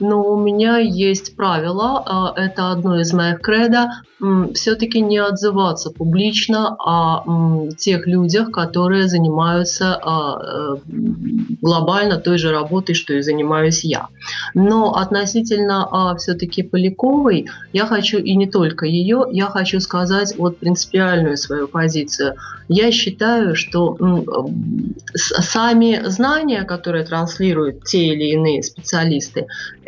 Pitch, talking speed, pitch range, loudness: 185 Hz, 110 wpm, 165-210 Hz, -17 LUFS